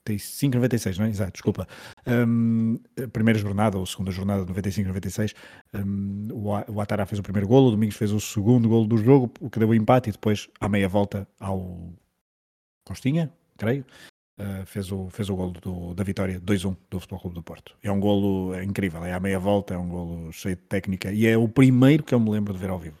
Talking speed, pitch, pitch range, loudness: 215 wpm, 100 Hz, 95-110 Hz, -24 LUFS